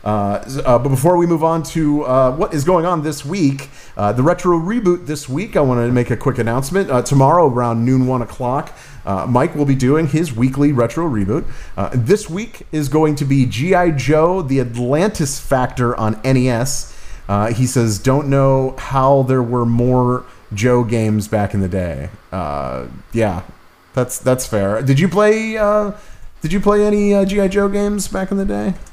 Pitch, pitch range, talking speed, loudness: 135 Hz, 120-170 Hz, 195 wpm, -16 LUFS